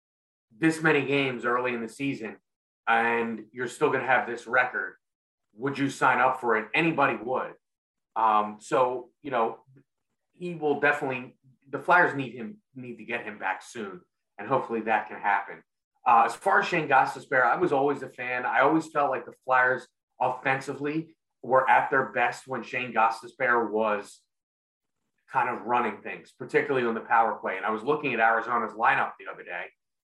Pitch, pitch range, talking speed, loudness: 125 Hz, 115-140 Hz, 180 wpm, -26 LUFS